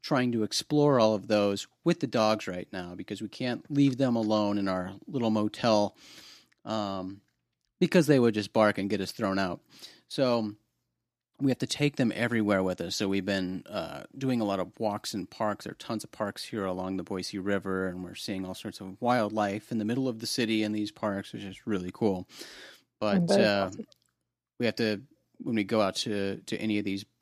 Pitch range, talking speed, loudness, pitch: 95-115 Hz, 210 wpm, -29 LUFS, 105 Hz